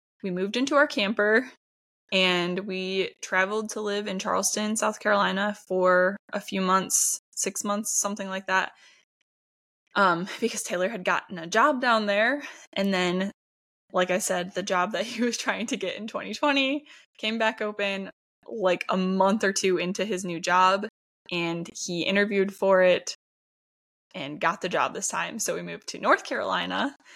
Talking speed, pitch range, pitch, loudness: 170 wpm, 185-215 Hz, 195 Hz, -25 LUFS